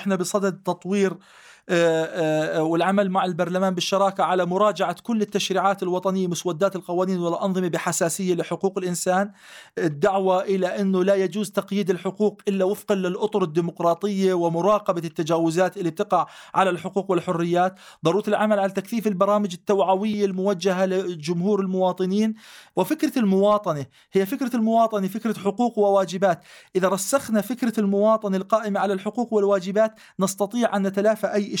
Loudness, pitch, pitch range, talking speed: -23 LUFS, 195 Hz, 180-205 Hz, 125 wpm